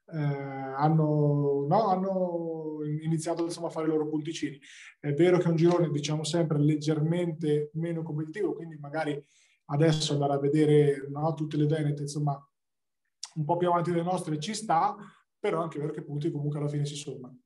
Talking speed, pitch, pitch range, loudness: 180 wpm, 155 Hz, 145-165 Hz, -28 LUFS